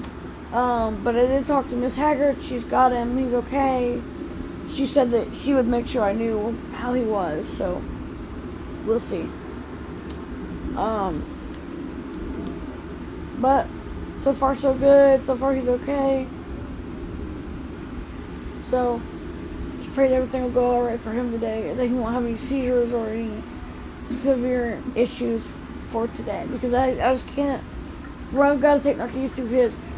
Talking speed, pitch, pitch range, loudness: 150 wpm, 245 Hz, 230-270 Hz, -23 LUFS